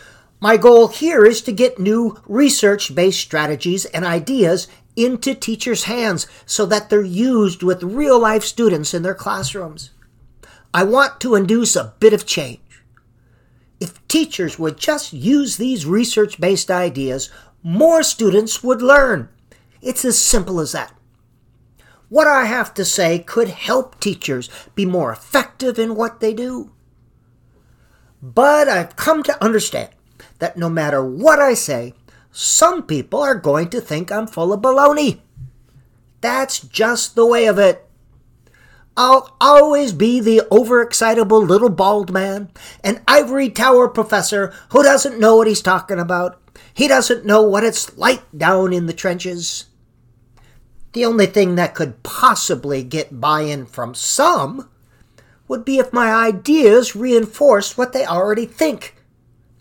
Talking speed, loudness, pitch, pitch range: 140 wpm, -15 LUFS, 205 Hz, 155-245 Hz